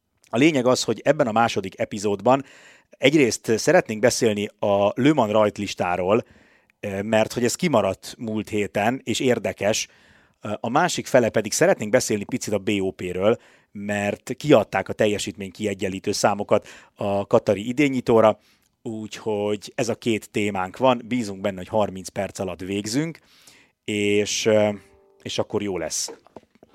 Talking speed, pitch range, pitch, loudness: 130 wpm, 100-120 Hz, 105 Hz, -22 LUFS